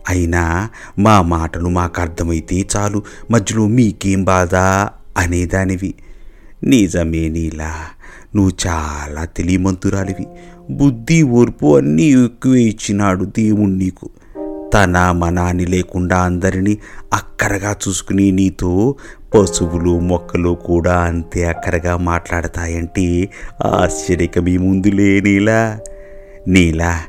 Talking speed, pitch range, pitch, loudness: 85 wpm, 85-100 Hz, 95 Hz, -15 LUFS